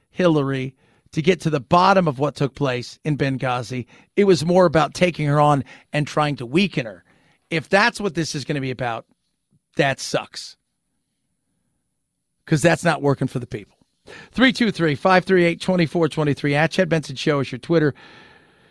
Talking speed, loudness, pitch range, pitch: 190 wpm, -20 LUFS, 140-175 Hz, 155 Hz